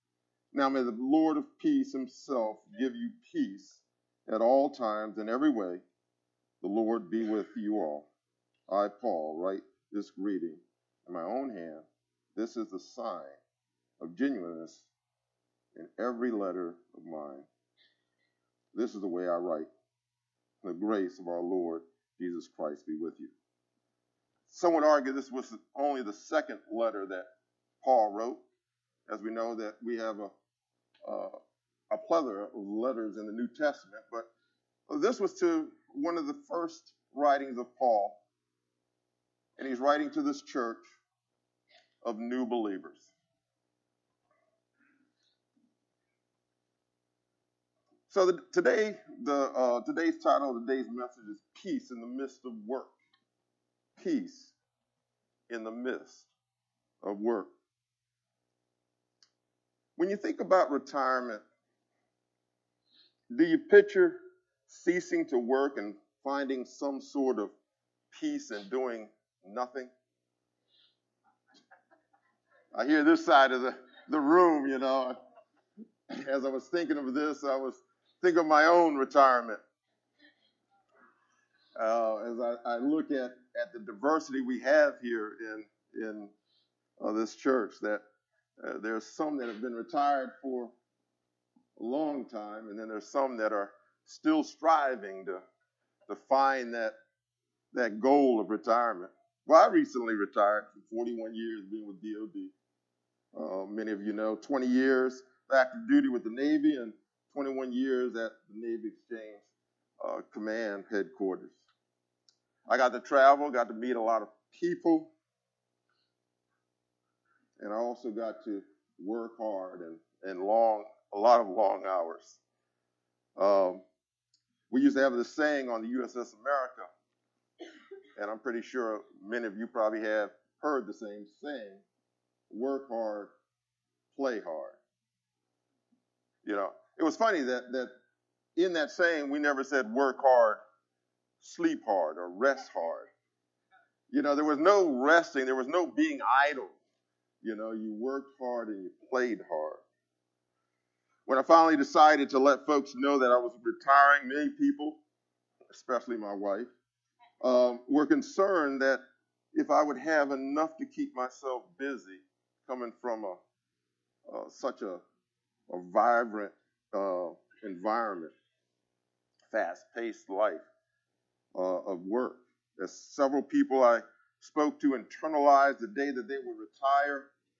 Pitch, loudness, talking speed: 115 Hz, -30 LUFS, 135 wpm